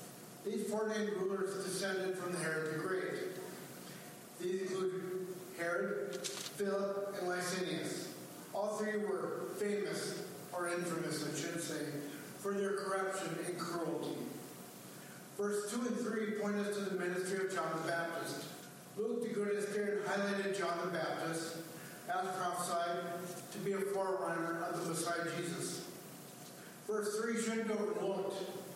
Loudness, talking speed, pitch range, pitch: -39 LUFS, 135 wpm, 170-200 Hz, 190 Hz